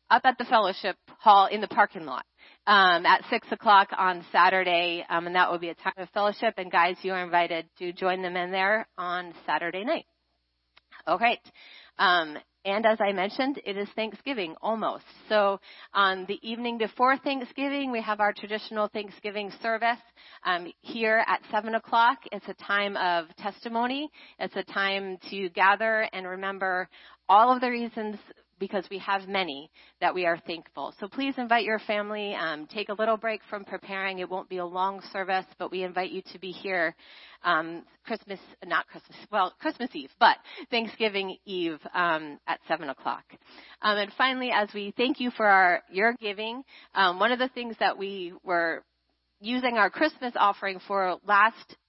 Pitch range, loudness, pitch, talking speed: 185-230 Hz, -27 LUFS, 200 Hz, 175 wpm